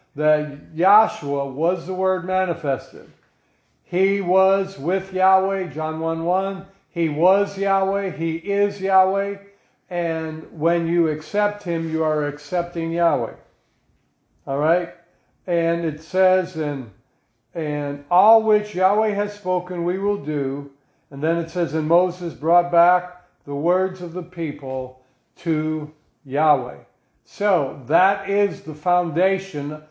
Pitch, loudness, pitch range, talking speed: 175 Hz, -21 LUFS, 155-190 Hz, 125 wpm